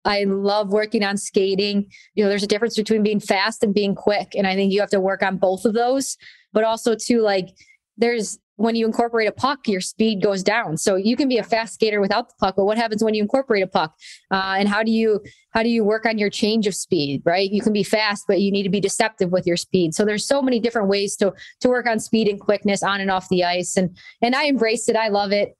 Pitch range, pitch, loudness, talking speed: 195-225 Hz, 210 Hz, -20 LUFS, 265 wpm